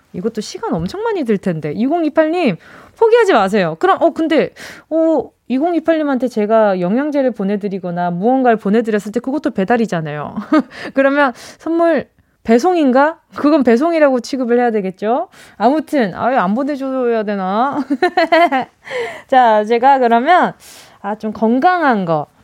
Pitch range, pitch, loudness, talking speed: 215-315 Hz, 255 Hz, -15 LUFS, 290 characters per minute